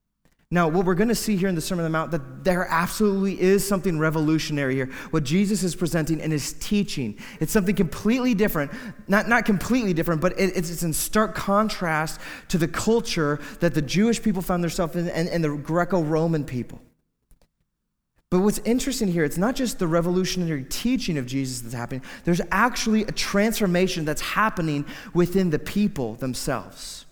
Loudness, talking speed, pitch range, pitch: -24 LUFS, 175 wpm, 155-205 Hz, 175 Hz